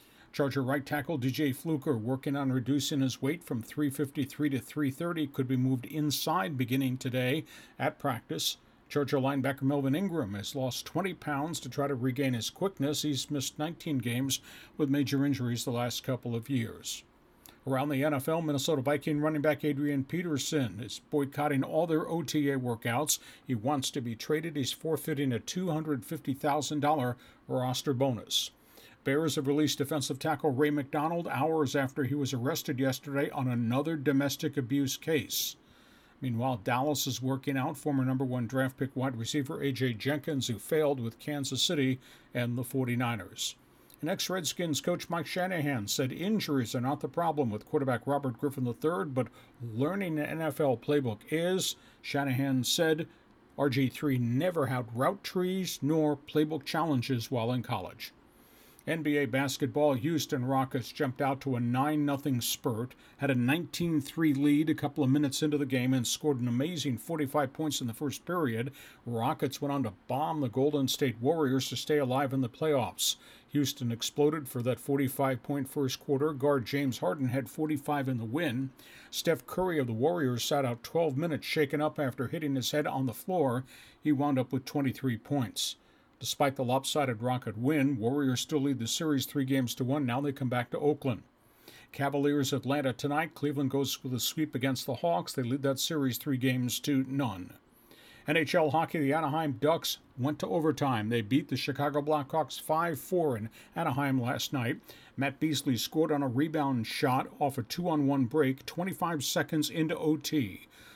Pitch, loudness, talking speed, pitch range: 140 Hz, -31 LUFS, 170 wpm, 130-150 Hz